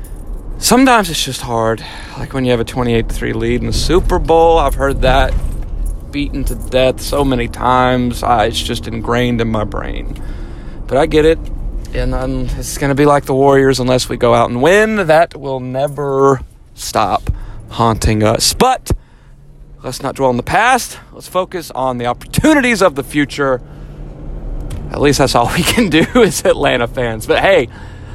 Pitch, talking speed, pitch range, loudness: 130 Hz, 175 wpm, 120-145 Hz, -14 LUFS